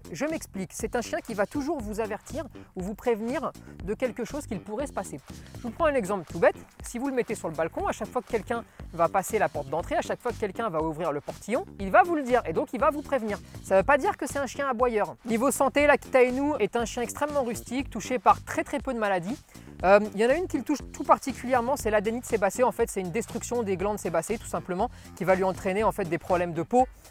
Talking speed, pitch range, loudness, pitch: 275 wpm, 200-270 Hz, -27 LUFS, 230 Hz